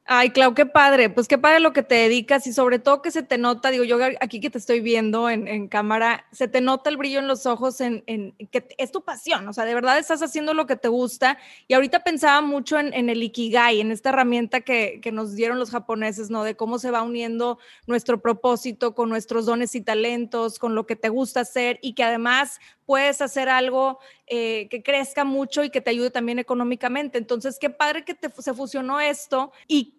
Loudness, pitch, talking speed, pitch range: -22 LUFS, 250 Hz, 225 wpm, 235-275 Hz